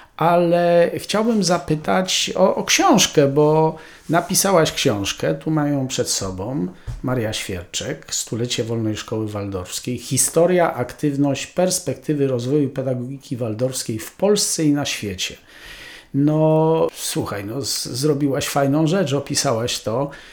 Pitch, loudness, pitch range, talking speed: 140 Hz, -19 LUFS, 120-160 Hz, 110 wpm